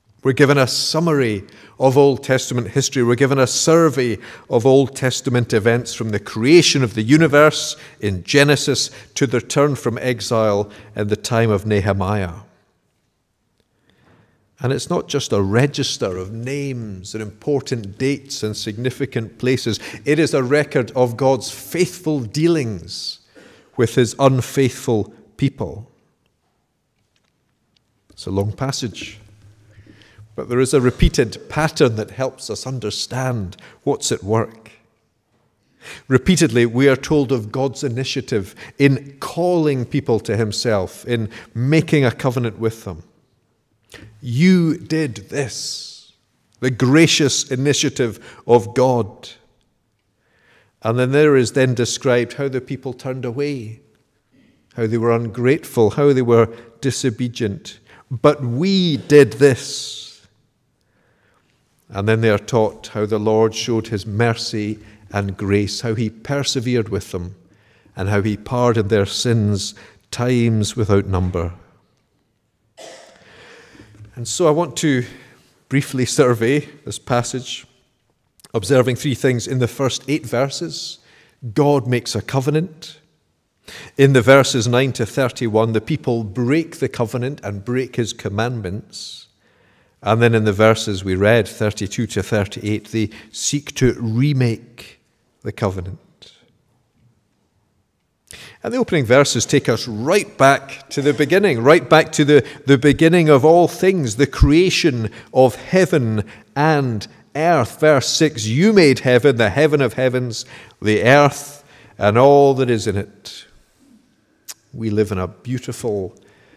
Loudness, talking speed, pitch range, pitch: -17 LUFS, 130 wpm, 110-140 Hz, 125 Hz